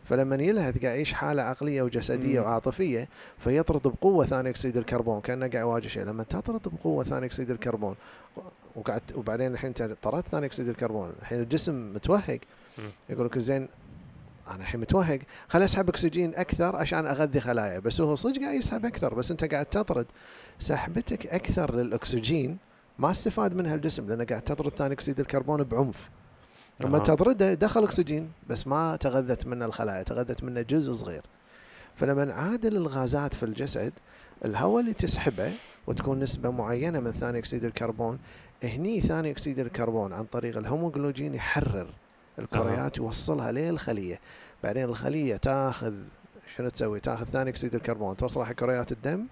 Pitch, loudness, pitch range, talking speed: 130 Hz, -29 LUFS, 120-155 Hz, 145 wpm